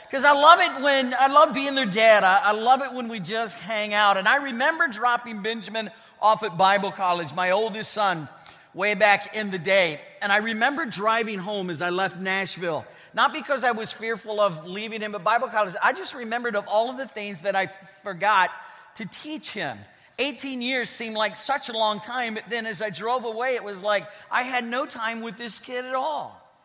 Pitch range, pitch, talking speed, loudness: 205-250 Hz, 220 Hz, 215 wpm, -23 LUFS